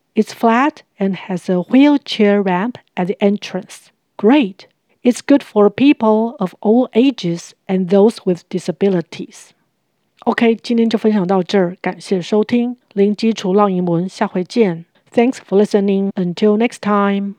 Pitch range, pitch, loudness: 185-230 Hz, 205 Hz, -16 LUFS